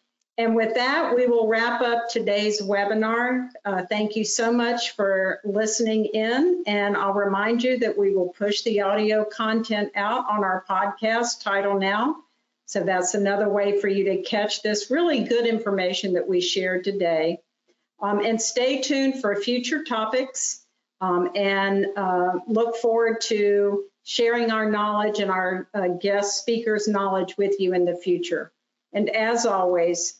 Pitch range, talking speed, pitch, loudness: 195-230 Hz, 160 wpm, 210 Hz, -23 LUFS